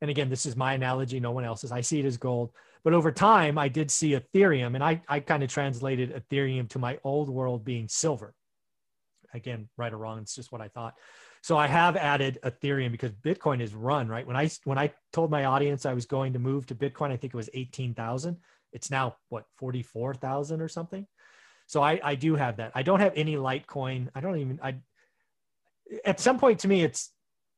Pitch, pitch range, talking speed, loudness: 135 Hz, 125-155 Hz, 215 wpm, -28 LUFS